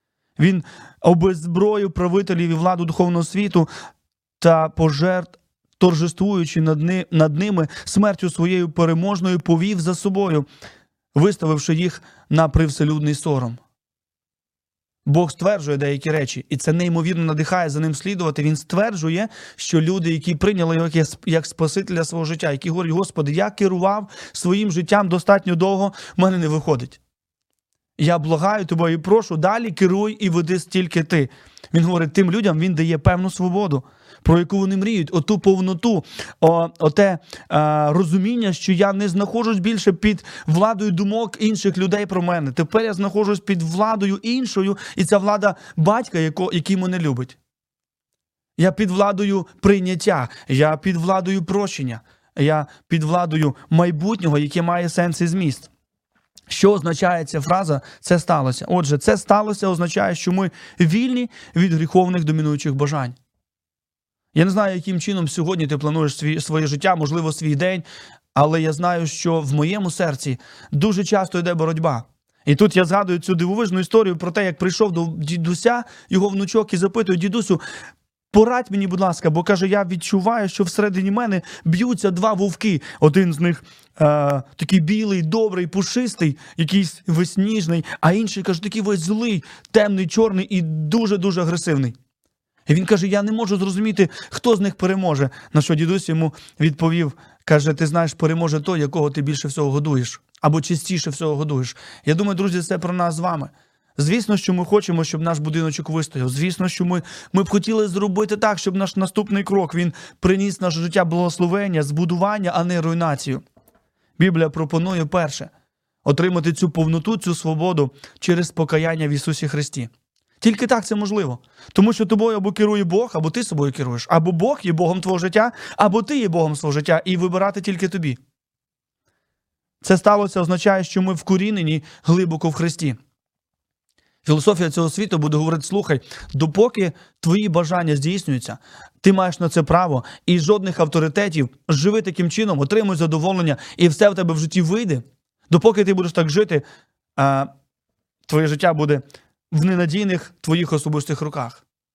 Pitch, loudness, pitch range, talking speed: 175 Hz, -19 LUFS, 155-195 Hz, 150 wpm